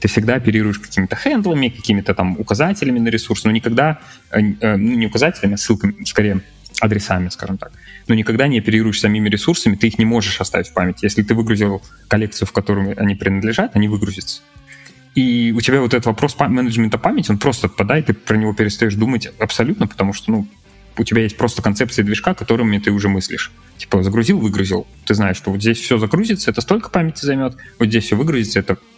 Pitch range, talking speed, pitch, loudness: 100-120 Hz, 195 wpm, 110 Hz, -17 LUFS